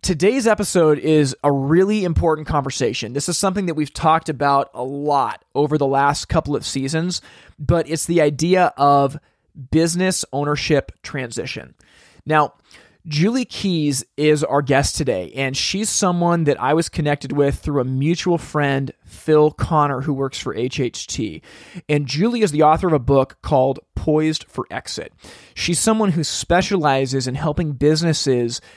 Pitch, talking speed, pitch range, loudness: 150 Hz, 155 wpm, 140-170 Hz, -19 LUFS